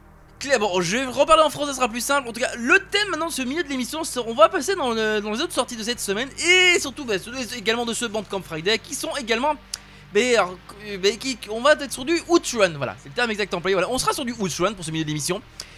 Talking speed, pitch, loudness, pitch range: 280 wpm, 245 Hz, -22 LUFS, 205-290 Hz